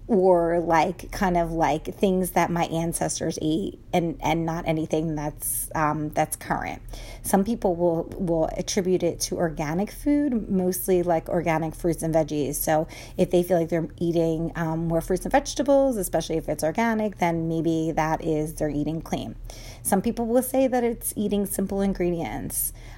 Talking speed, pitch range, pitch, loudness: 170 wpm, 160-190 Hz, 170 Hz, -25 LUFS